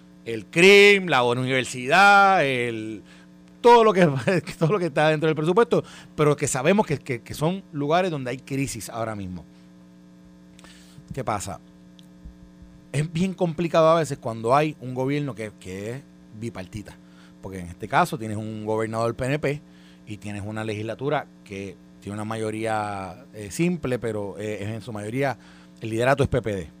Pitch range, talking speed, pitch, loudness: 95-150 Hz, 160 wpm, 115 Hz, -22 LUFS